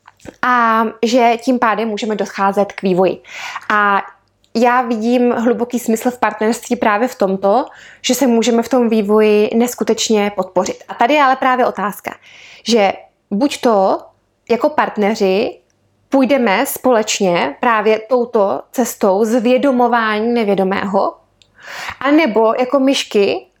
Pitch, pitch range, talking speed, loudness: 230 Hz, 210-250 Hz, 120 wpm, -15 LUFS